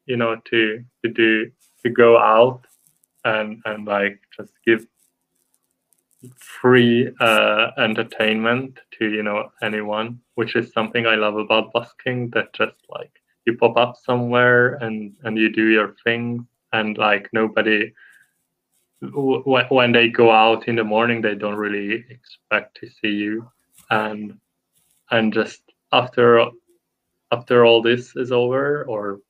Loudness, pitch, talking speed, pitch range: -19 LUFS, 115 Hz, 135 wpm, 110-120 Hz